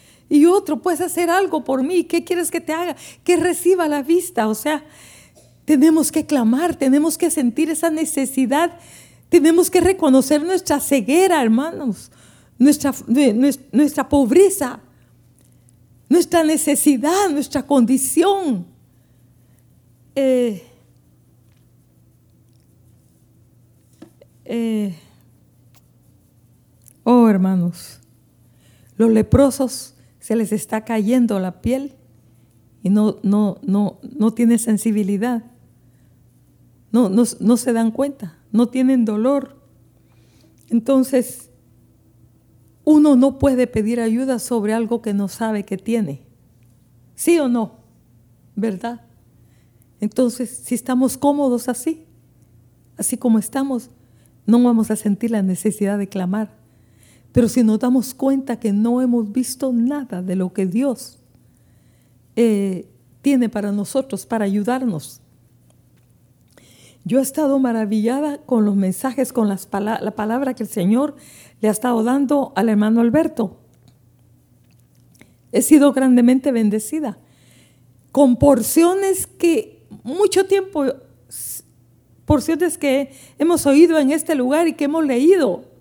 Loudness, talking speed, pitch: -18 LUFS, 115 wpm, 230 Hz